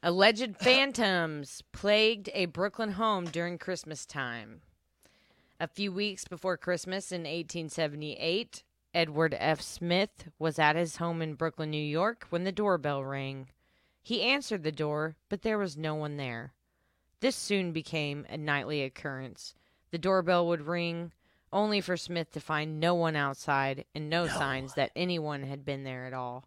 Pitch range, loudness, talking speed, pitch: 145-185 Hz, -31 LUFS, 155 wpm, 165 Hz